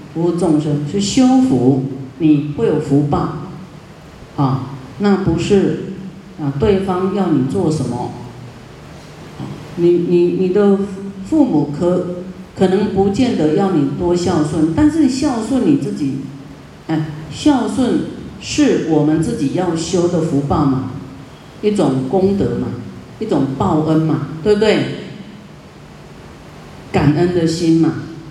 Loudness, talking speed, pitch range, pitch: -16 LUFS, 170 characters per minute, 150-195 Hz, 170 Hz